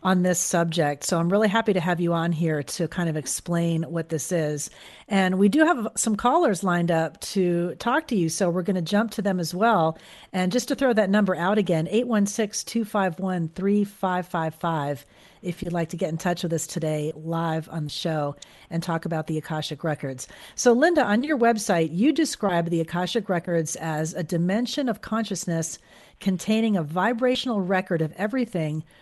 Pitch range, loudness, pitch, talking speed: 165-210 Hz, -24 LUFS, 180 Hz, 190 wpm